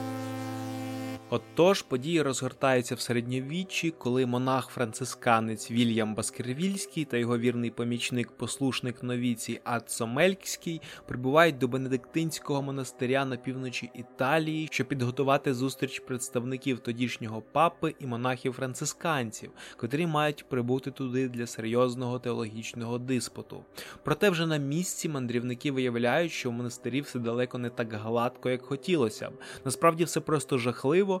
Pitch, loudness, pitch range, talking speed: 130 Hz, -30 LUFS, 120-140 Hz, 120 wpm